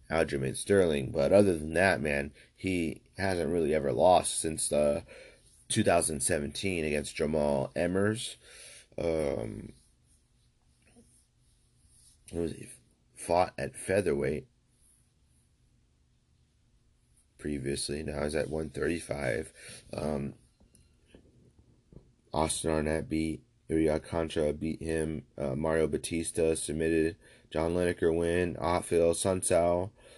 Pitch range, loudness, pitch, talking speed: 75-85 Hz, -30 LUFS, 80 Hz, 95 wpm